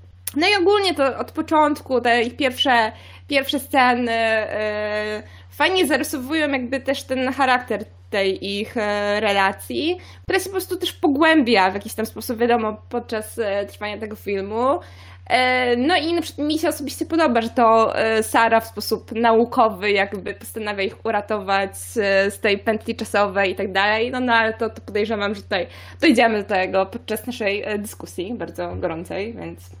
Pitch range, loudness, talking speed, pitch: 205-265 Hz, -20 LUFS, 165 wpm, 225 Hz